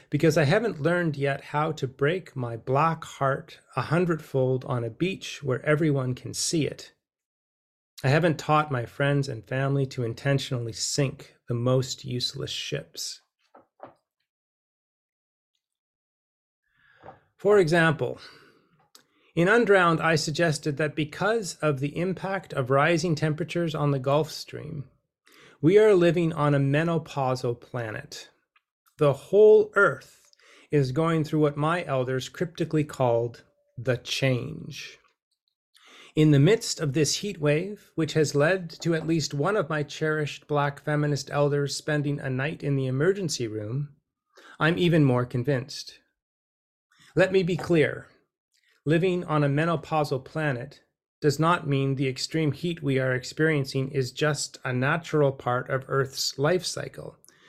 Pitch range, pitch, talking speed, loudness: 135-165 Hz, 145 Hz, 135 wpm, -25 LUFS